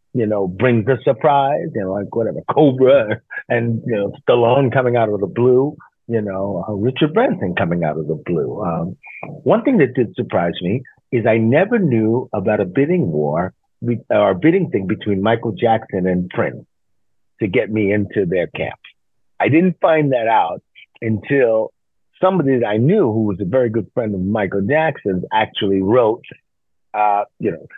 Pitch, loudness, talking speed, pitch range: 115 Hz, -17 LUFS, 180 wpm, 100-130 Hz